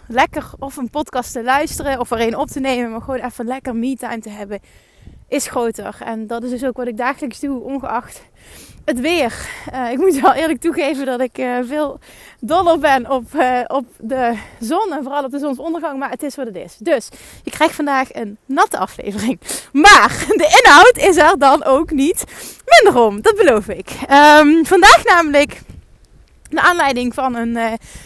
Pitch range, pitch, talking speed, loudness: 245-300 Hz, 270 Hz, 190 wpm, -14 LUFS